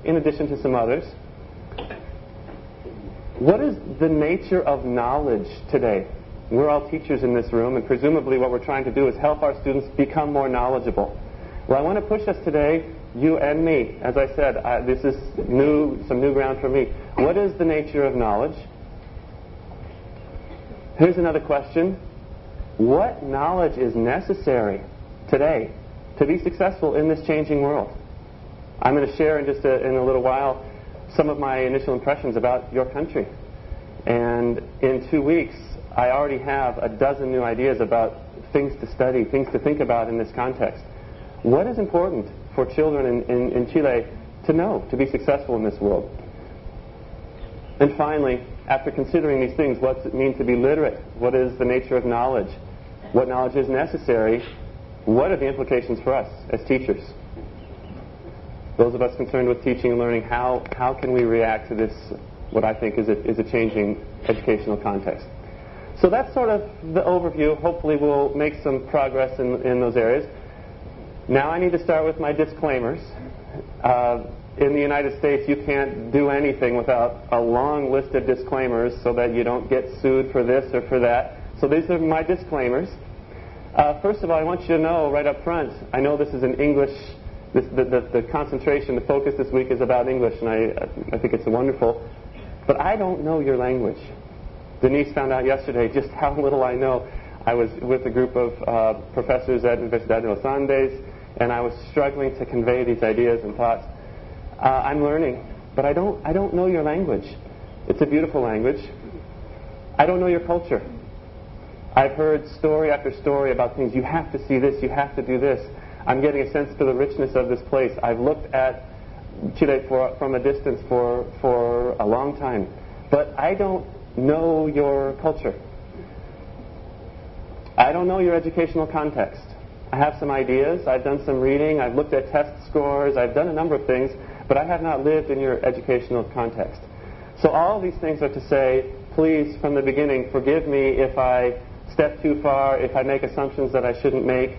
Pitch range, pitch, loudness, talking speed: 120-145 Hz, 130 Hz, -22 LUFS, 185 wpm